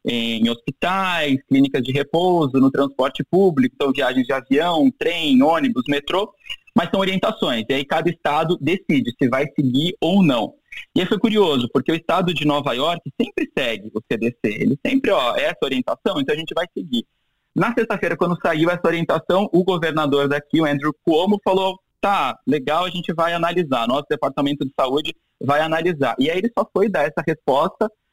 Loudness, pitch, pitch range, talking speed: -20 LUFS, 165 Hz, 140-195 Hz, 185 wpm